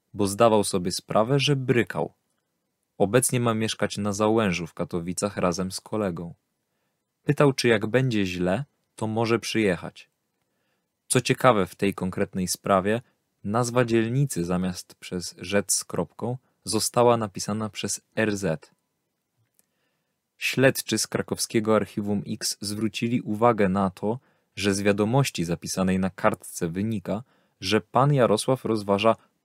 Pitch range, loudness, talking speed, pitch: 95-115 Hz, -25 LUFS, 125 wpm, 105 Hz